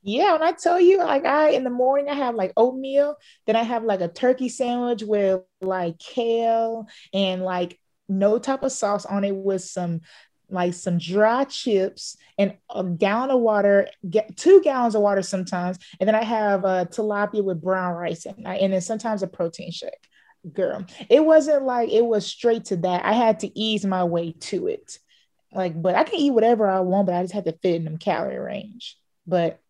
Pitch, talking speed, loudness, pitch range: 205 Hz, 205 wpm, -22 LUFS, 185-245 Hz